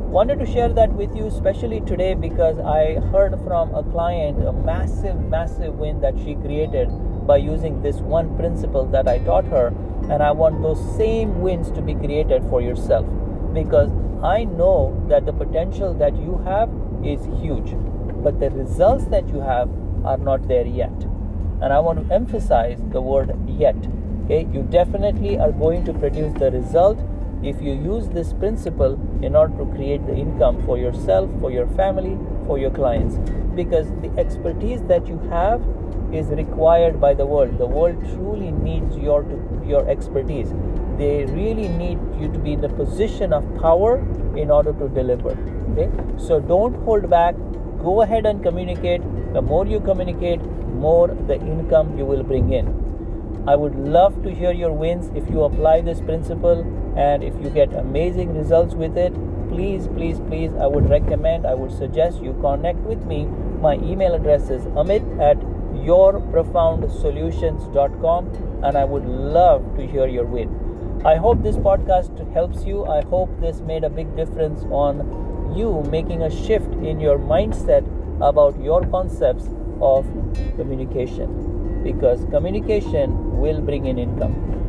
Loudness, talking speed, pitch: -20 LUFS, 165 wpm, 125 Hz